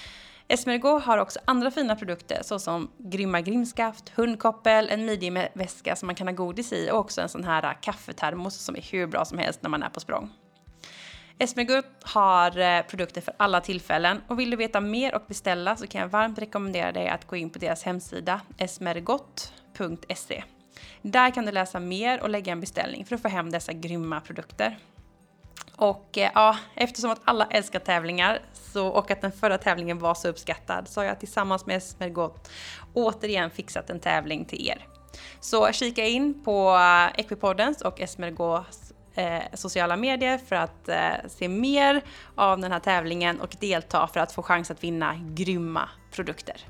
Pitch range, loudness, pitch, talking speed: 175-220 Hz, -26 LUFS, 190 Hz, 170 wpm